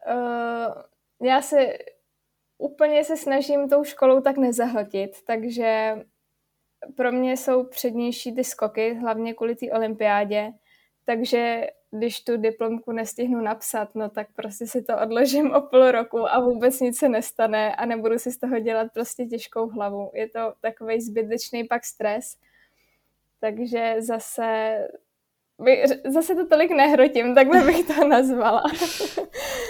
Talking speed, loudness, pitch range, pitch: 135 wpm, -22 LUFS, 225-265 Hz, 235 Hz